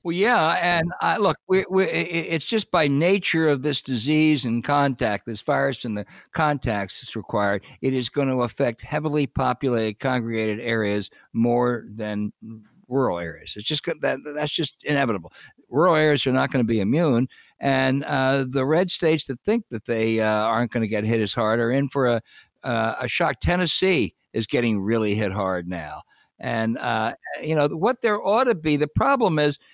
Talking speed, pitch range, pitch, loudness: 190 wpm, 115-155 Hz, 130 Hz, -23 LUFS